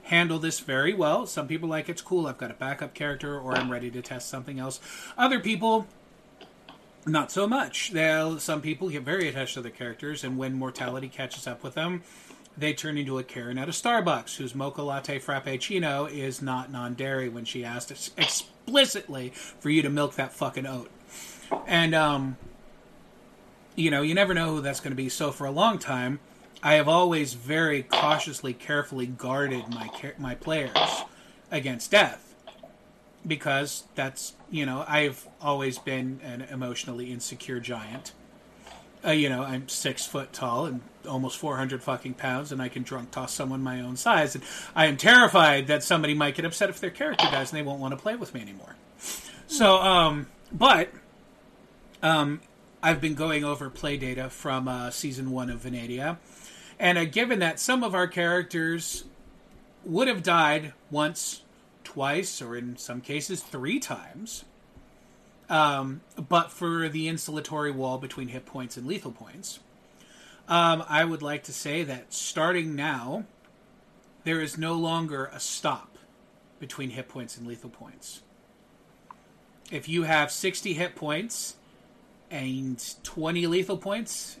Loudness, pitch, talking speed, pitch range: -27 LUFS, 145 Hz, 165 wpm, 130-170 Hz